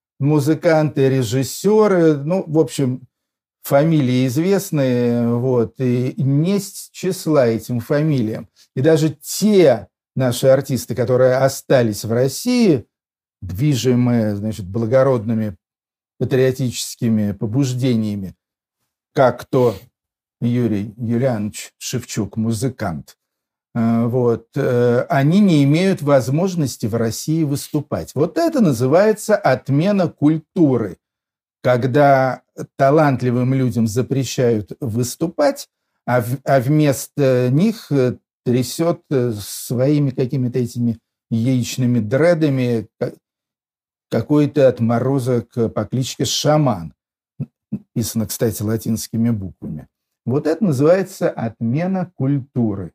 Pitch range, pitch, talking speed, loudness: 115-150 Hz, 130 Hz, 85 wpm, -18 LUFS